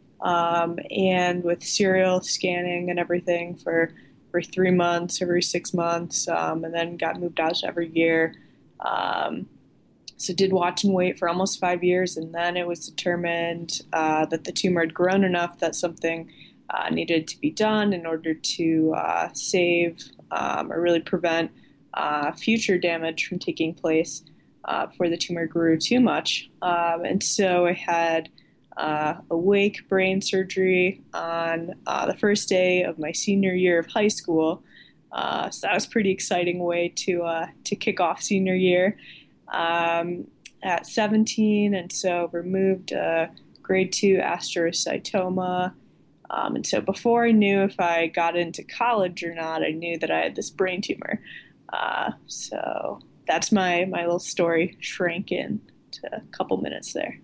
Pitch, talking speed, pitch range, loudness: 175 Hz, 160 wpm, 165-190 Hz, -24 LUFS